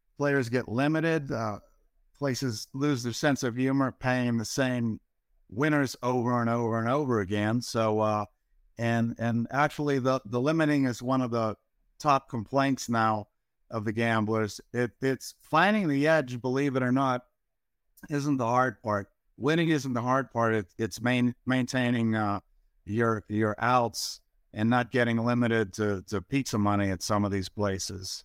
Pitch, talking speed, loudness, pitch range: 120 Hz, 165 wpm, -28 LUFS, 110-135 Hz